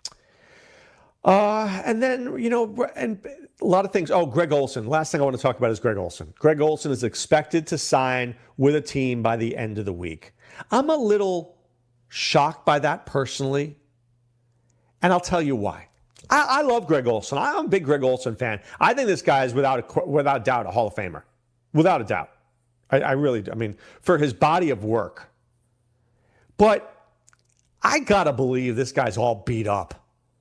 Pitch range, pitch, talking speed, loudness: 120-175 Hz, 135 Hz, 195 wpm, -22 LUFS